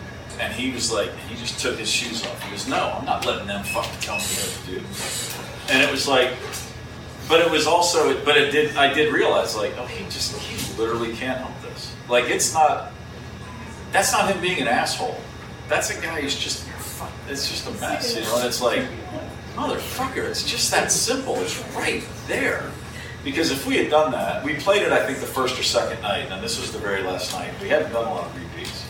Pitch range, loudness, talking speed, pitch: 120-150 Hz, -22 LUFS, 210 wpm, 130 Hz